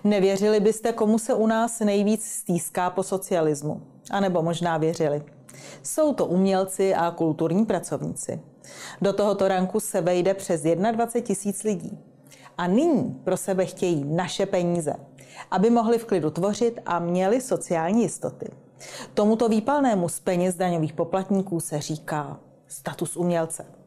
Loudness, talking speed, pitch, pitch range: -24 LUFS, 140 wpm, 185 Hz, 165-210 Hz